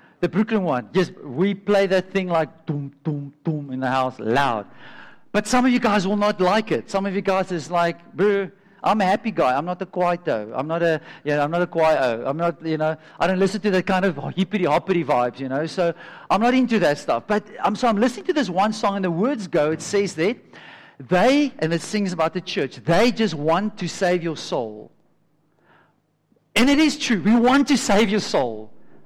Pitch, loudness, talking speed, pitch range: 185 Hz, -21 LUFS, 225 wpm, 160-210 Hz